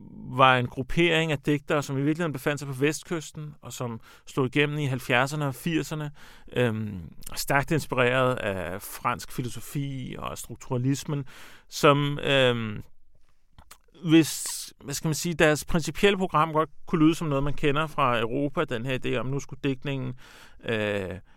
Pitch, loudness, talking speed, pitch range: 140 Hz, -26 LUFS, 155 wpm, 125-150 Hz